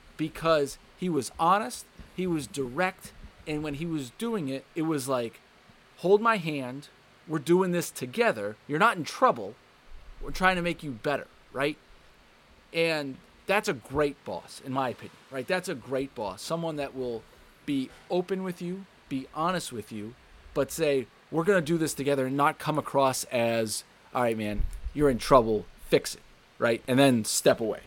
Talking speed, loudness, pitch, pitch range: 180 wpm, -28 LUFS, 145 Hz, 125-175 Hz